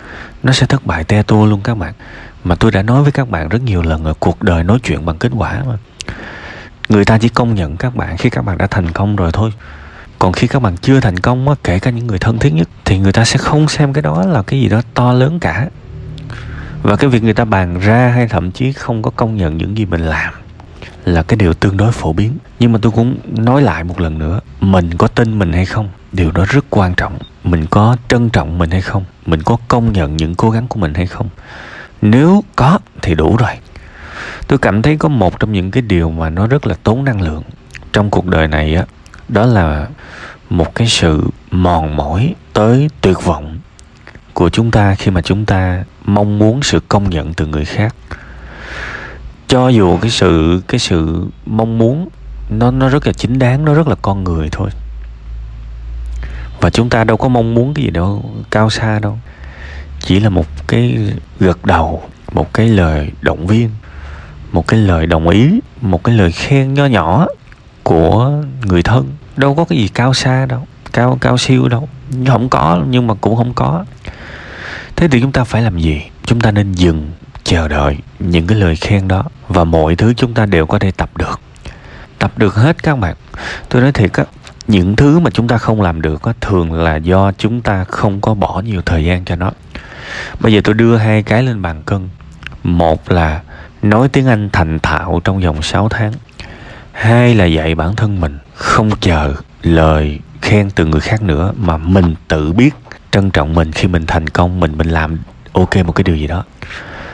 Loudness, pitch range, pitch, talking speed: -13 LUFS, 85-120 Hz, 100 Hz, 210 wpm